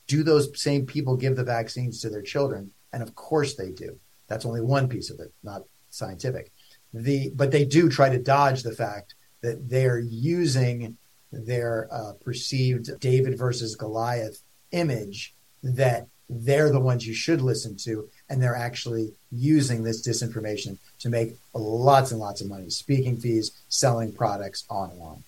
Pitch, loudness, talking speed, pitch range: 120 Hz, -25 LUFS, 160 wpm, 115-135 Hz